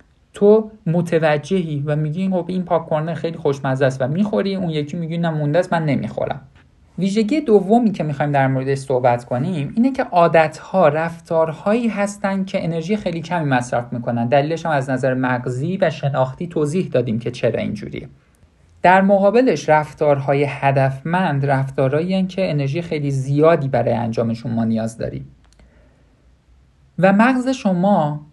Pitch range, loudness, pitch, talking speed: 135-185 Hz, -18 LUFS, 155 Hz, 140 wpm